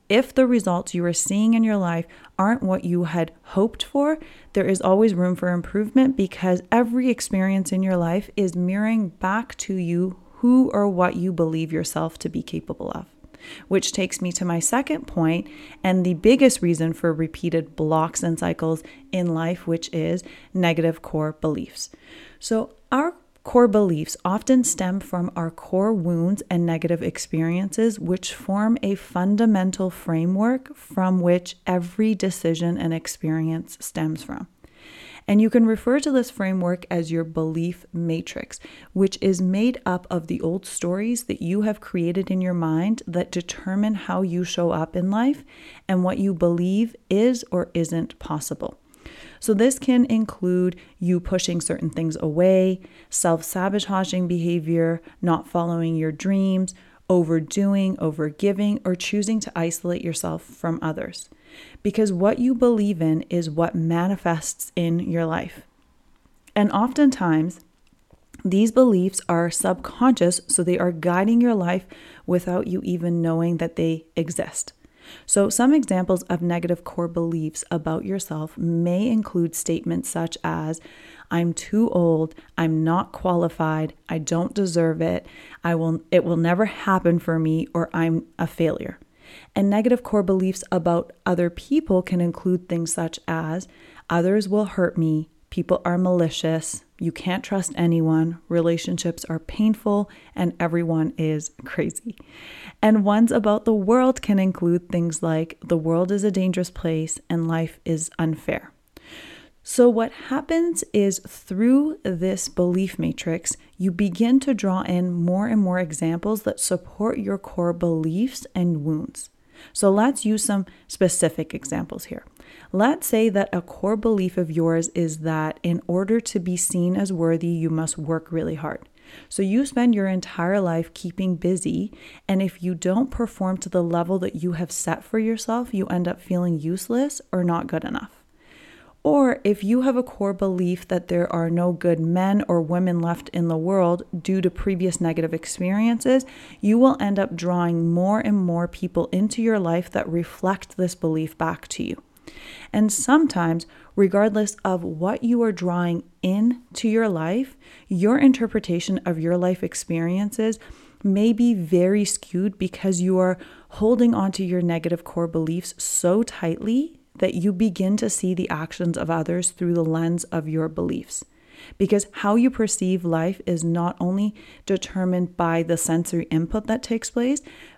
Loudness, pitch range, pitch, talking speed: -22 LUFS, 170-210 Hz, 180 Hz, 155 wpm